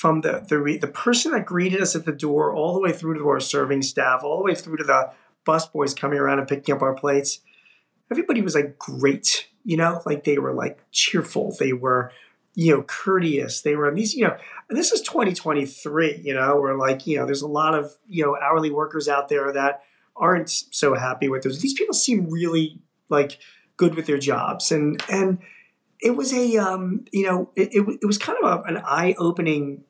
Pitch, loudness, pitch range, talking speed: 155 Hz, -22 LUFS, 140-190 Hz, 220 wpm